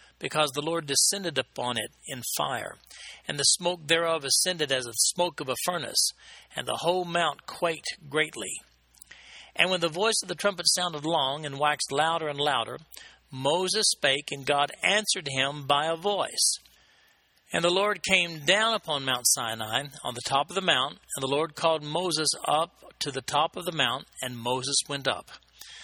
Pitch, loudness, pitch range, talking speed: 155 Hz, -26 LUFS, 135-175 Hz, 180 wpm